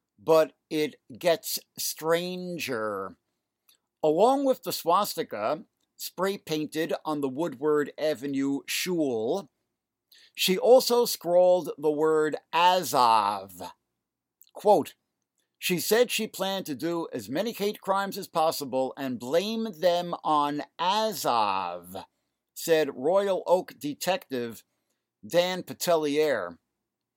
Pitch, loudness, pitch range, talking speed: 165 Hz, -27 LUFS, 150-190 Hz, 100 wpm